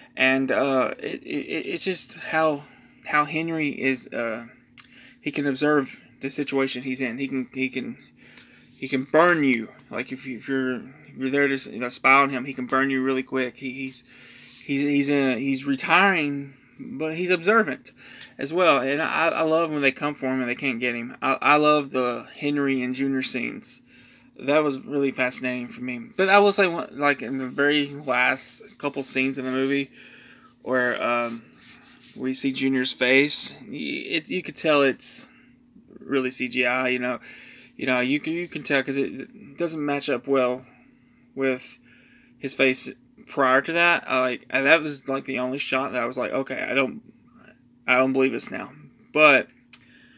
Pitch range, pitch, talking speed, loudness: 130-150 Hz, 135 Hz, 190 wpm, -23 LUFS